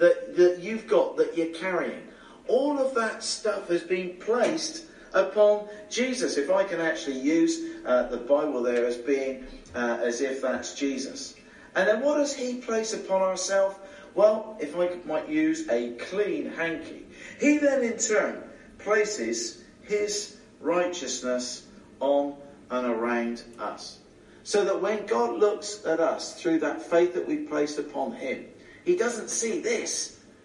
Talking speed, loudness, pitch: 155 wpm, -27 LUFS, 195 Hz